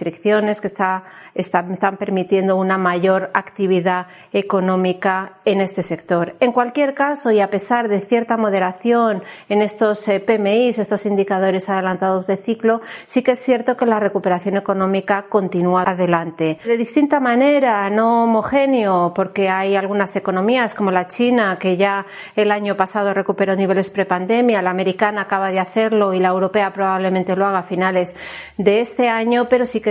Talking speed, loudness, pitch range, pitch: 155 wpm, -18 LUFS, 190-220 Hz, 200 Hz